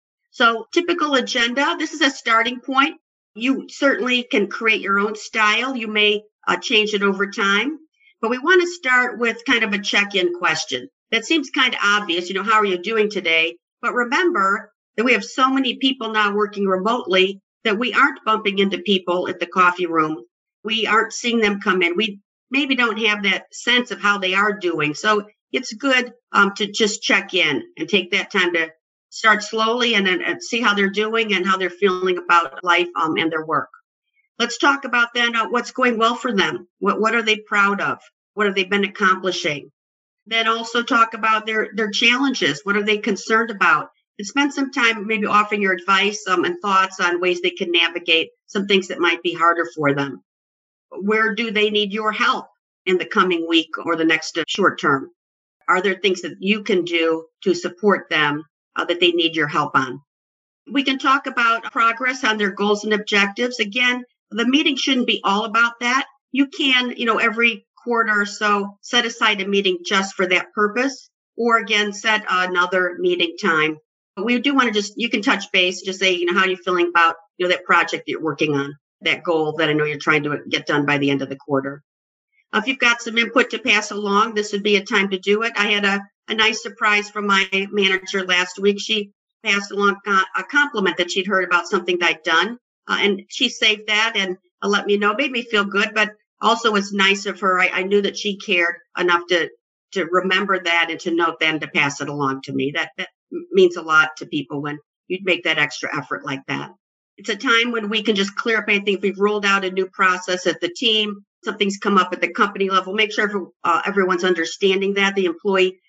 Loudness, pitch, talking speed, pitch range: -19 LUFS, 205 Hz, 215 wpm, 180-230 Hz